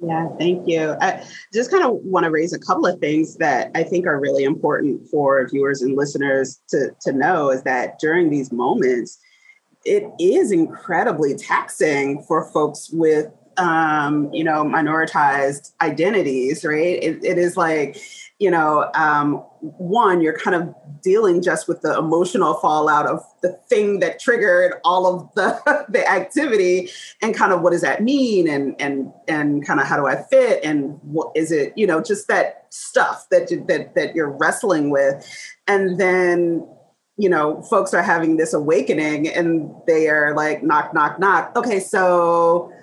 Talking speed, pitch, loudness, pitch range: 170 wpm, 165 Hz, -18 LUFS, 150-205 Hz